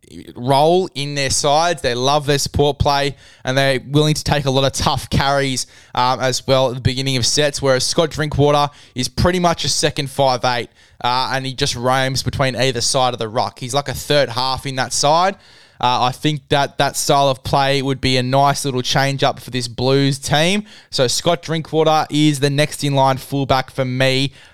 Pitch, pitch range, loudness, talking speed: 135 Hz, 130-145 Hz, -17 LUFS, 210 wpm